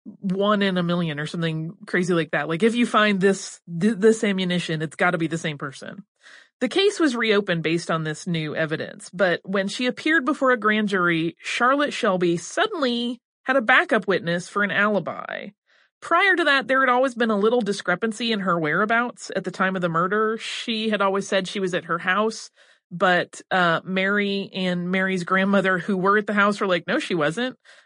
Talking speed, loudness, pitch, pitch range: 200 wpm, -22 LUFS, 200 Hz, 180-230 Hz